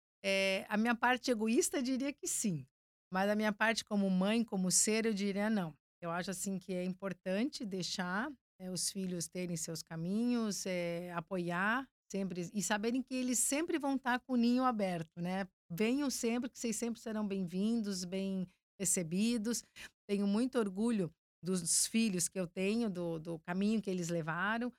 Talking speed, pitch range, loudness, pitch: 175 wpm, 185-230 Hz, -35 LUFS, 200 Hz